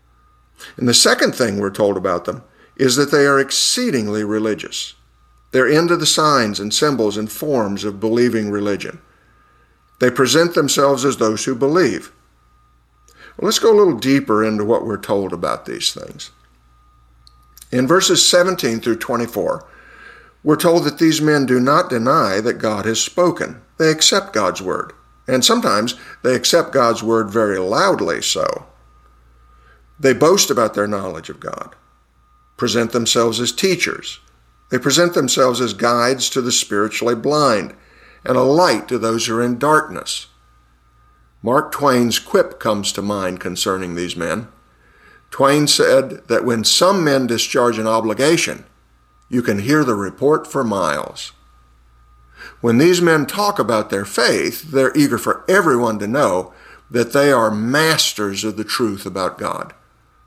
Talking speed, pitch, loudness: 150 wpm, 110 Hz, -16 LUFS